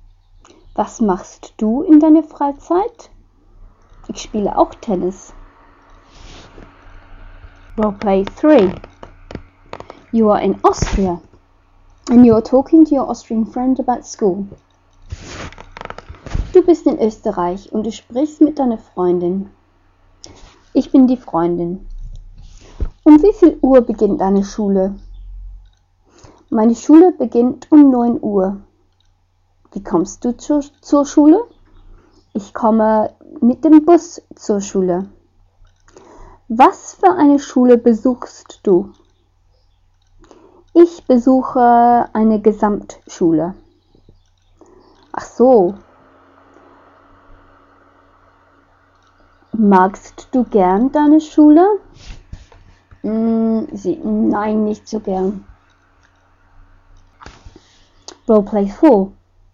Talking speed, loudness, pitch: 95 wpm, -14 LUFS, 195 Hz